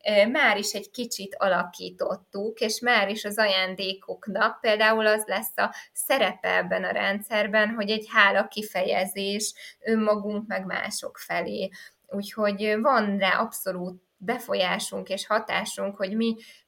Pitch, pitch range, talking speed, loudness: 210 Hz, 195-220 Hz, 125 wpm, -25 LUFS